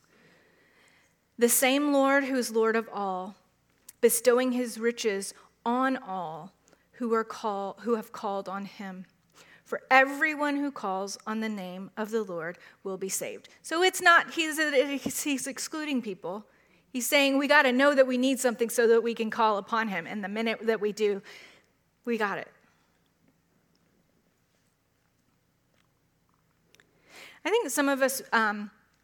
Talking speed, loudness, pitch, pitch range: 150 wpm, -27 LUFS, 230 Hz, 205-270 Hz